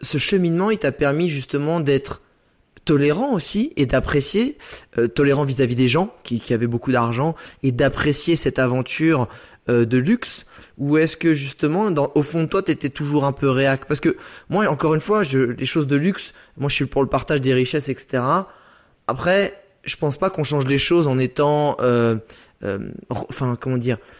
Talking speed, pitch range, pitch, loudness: 190 wpm, 130-160 Hz, 145 Hz, -20 LUFS